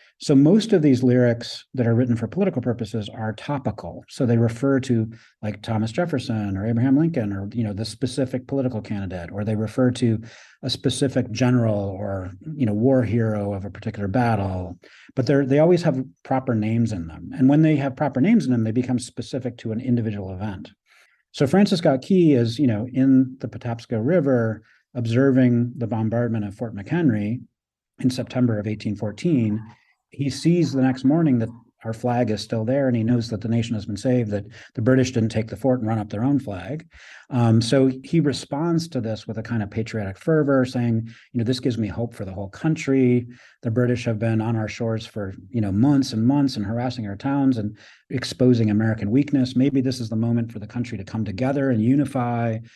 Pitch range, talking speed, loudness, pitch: 110-130 Hz, 205 wpm, -22 LUFS, 120 Hz